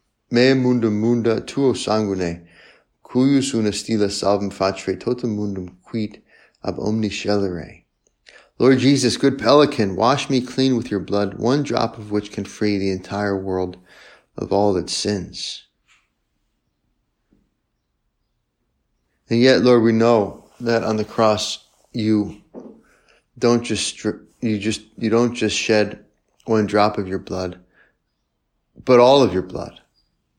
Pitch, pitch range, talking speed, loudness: 110 Hz, 100-120 Hz, 125 wpm, -19 LUFS